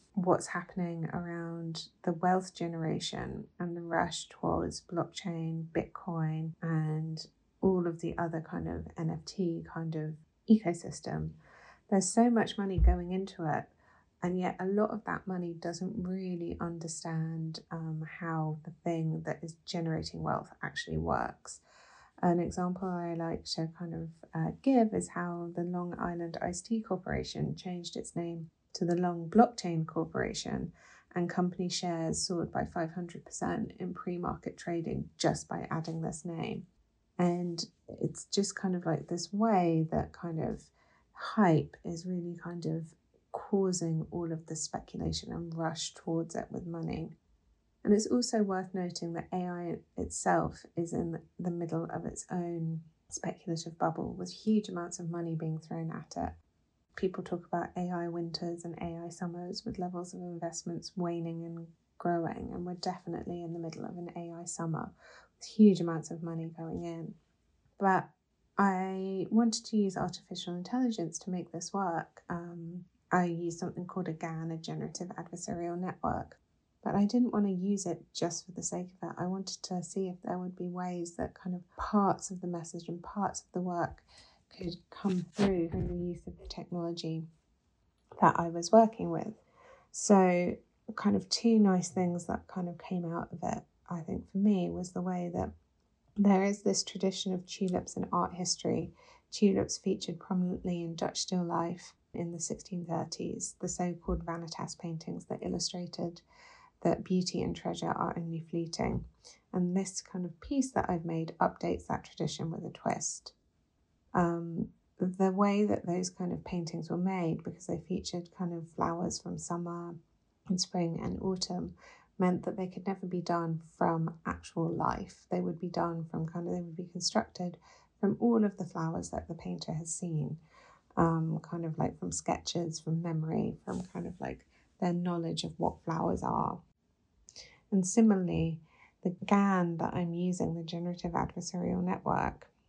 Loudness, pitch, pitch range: -34 LUFS, 175 Hz, 165-185 Hz